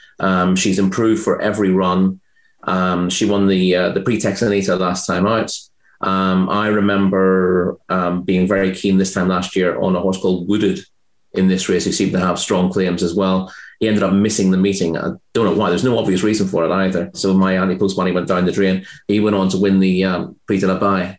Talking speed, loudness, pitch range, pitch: 220 wpm, -17 LUFS, 90-100 Hz, 95 Hz